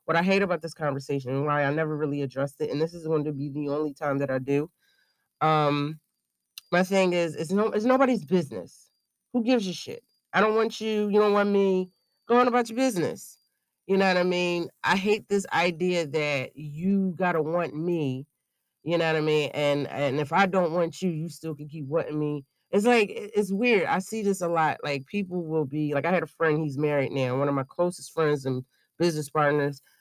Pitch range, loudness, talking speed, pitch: 145-195 Hz, -26 LUFS, 220 wpm, 160 Hz